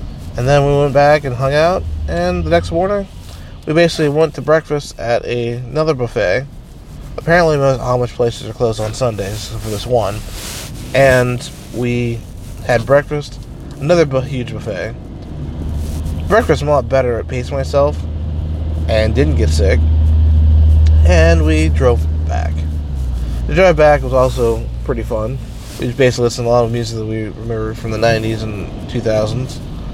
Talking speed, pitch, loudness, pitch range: 160 wpm, 110 Hz, -15 LUFS, 80-130 Hz